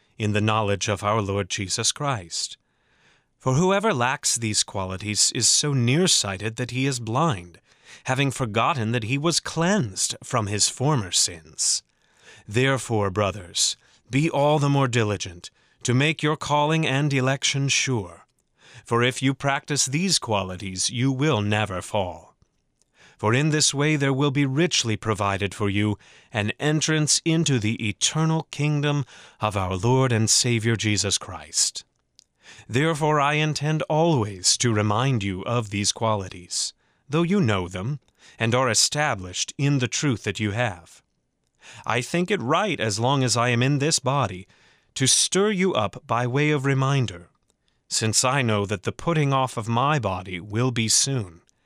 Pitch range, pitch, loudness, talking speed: 105-145 Hz, 125 Hz, -23 LUFS, 155 wpm